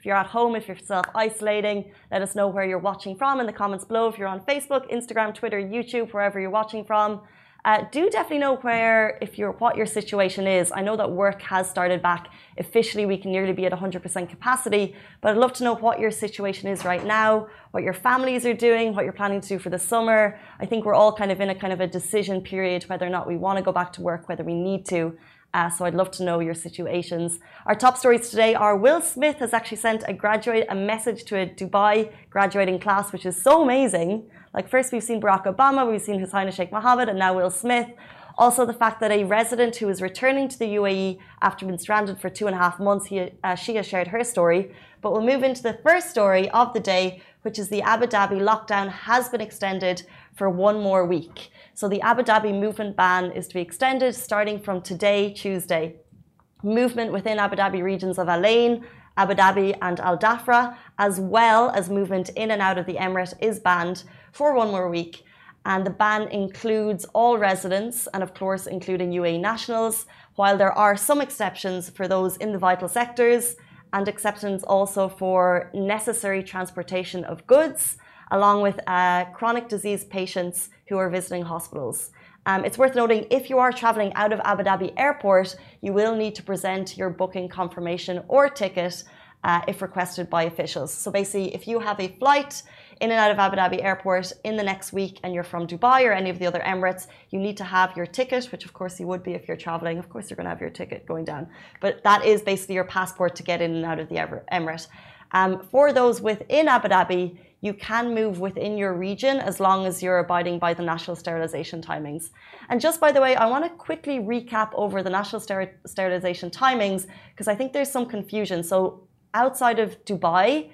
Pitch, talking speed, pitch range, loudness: 195 Hz, 215 wpm, 185-225 Hz, -23 LUFS